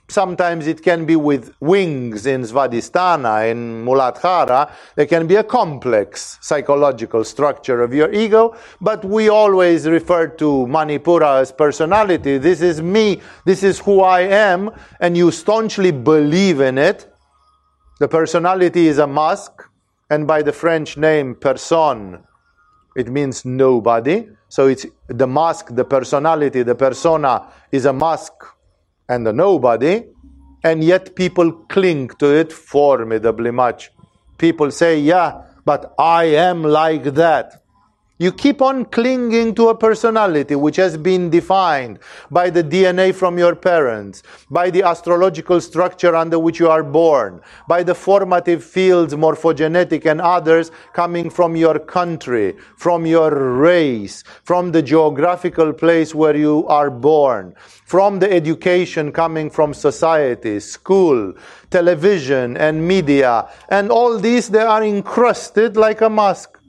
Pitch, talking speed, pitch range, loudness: 165 Hz, 135 wpm, 145-180 Hz, -15 LUFS